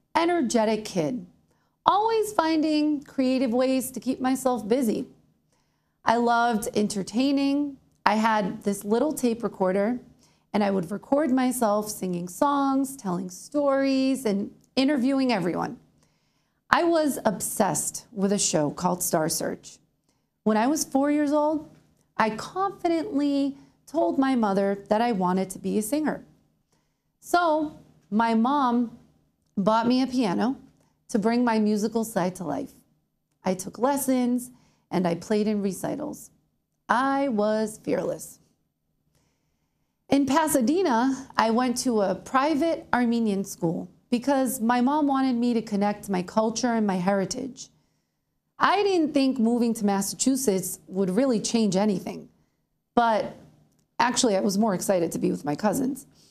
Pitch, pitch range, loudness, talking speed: 235 Hz, 205-270 Hz, -25 LUFS, 135 wpm